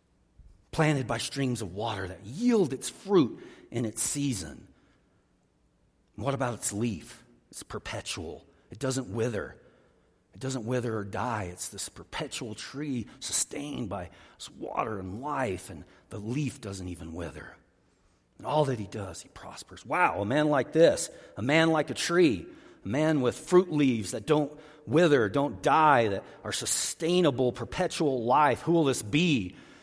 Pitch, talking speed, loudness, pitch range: 125 Hz, 155 wpm, -28 LUFS, 100-145 Hz